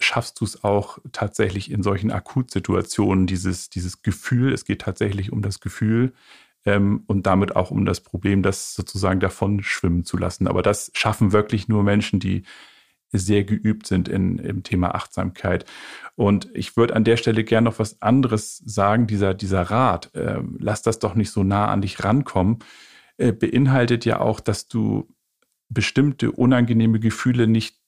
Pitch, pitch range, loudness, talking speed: 105 Hz, 100-115 Hz, -21 LUFS, 170 wpm